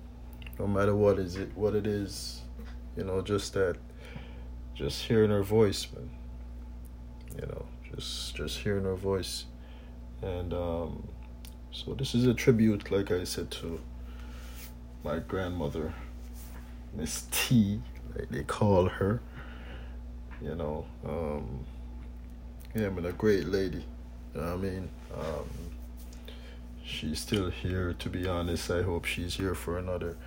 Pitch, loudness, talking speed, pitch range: 75 Hz, -32 LUFS, 140 wpm, 60-95 Hz